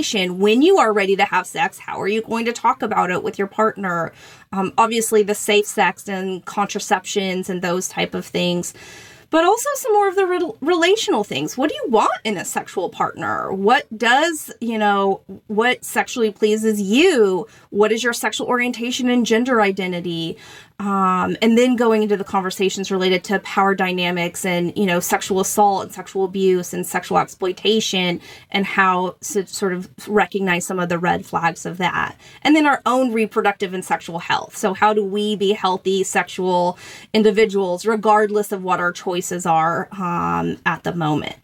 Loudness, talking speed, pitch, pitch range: -19 LUFS, 180 wpm, 200 Hz, 185-220 Hz